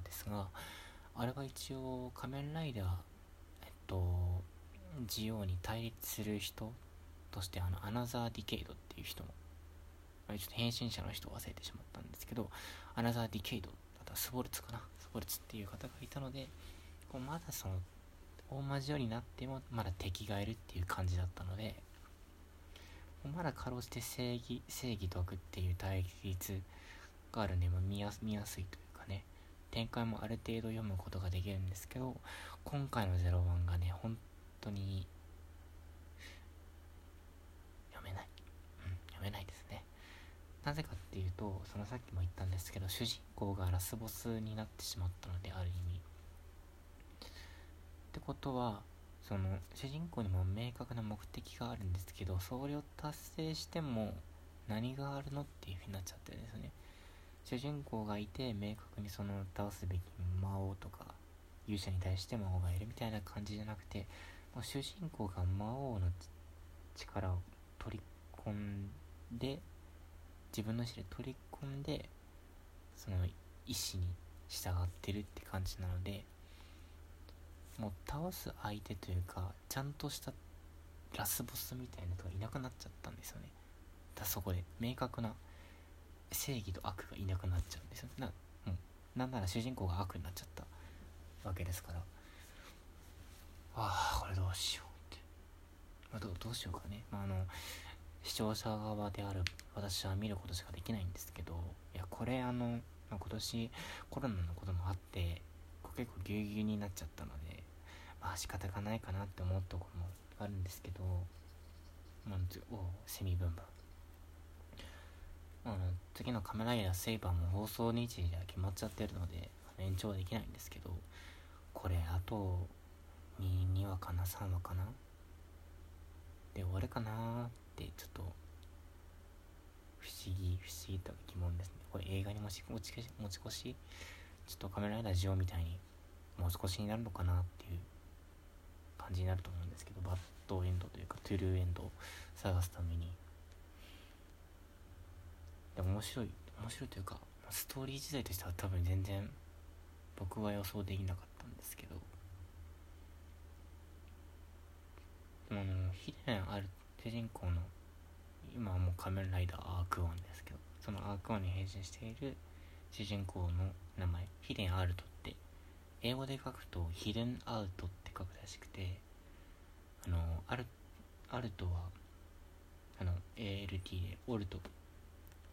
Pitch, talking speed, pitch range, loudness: 90 Hz, 305 characters per minute, 80-105 Hz, -43 LUFS